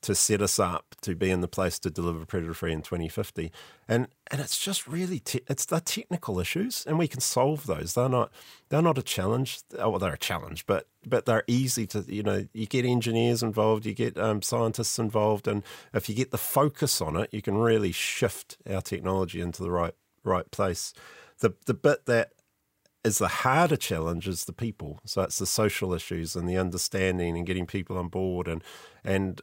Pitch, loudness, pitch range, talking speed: 105 Hz, -28 LUFS, 90-120 Hz, 210 wpm